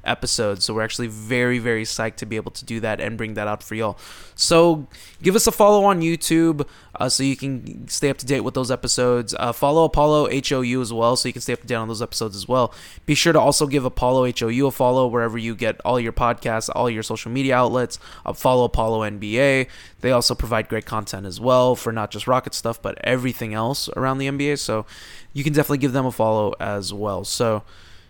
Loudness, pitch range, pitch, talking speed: -21 LUFS, 110-135 Hz, 120 Hz, 230 wpm